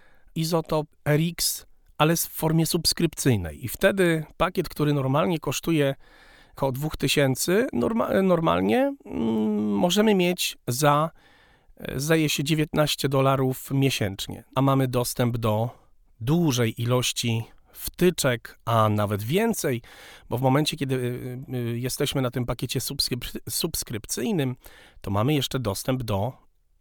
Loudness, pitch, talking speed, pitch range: -24 LUFS, 135 Hz, 105 wpm, 125-160 Hz